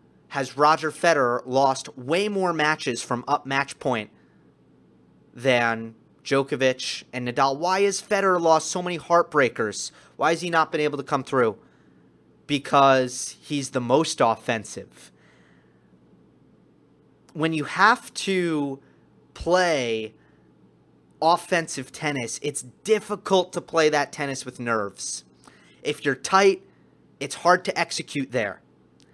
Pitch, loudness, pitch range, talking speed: 140 Hz, -23 LUFS, 120-165 Hz, 120 wpm